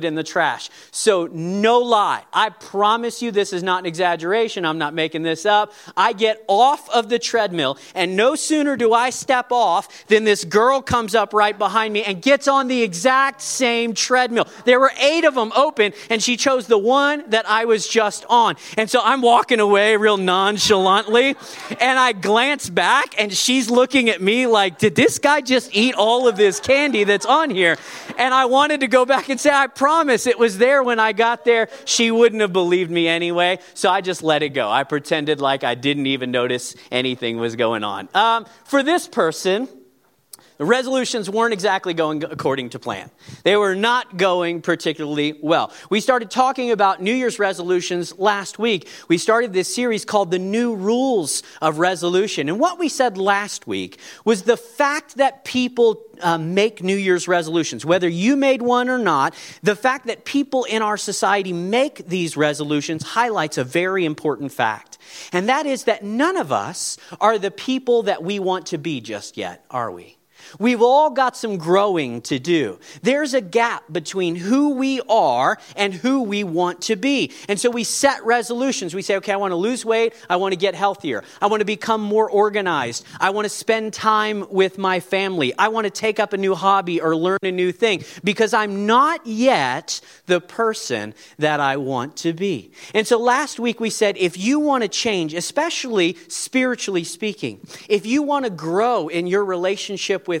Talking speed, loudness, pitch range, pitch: 195 wpm, -19 LUFS, 180-240 Hz, 210 Hz